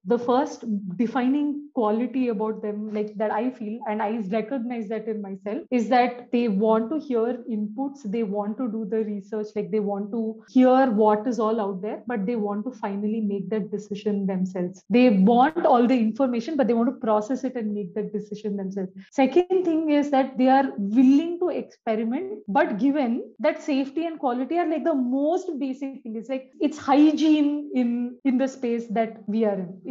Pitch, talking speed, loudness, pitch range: 235 Hz, 195 wpm, -24 LUFS, 215-270 Hz